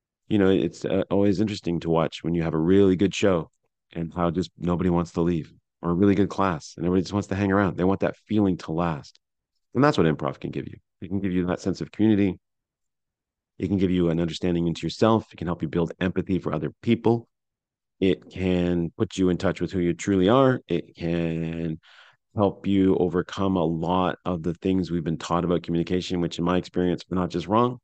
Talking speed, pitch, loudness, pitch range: 230 wpm, 90 Hz, -24 LUFS, 85-95 Hz